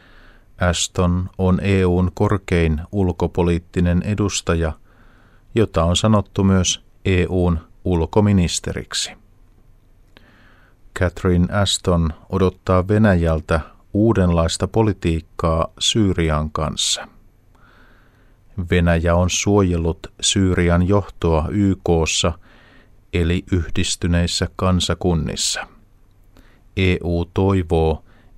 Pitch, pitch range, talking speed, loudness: 95 Hz, 85-105 Hz, 65 wpm, -19 LUFS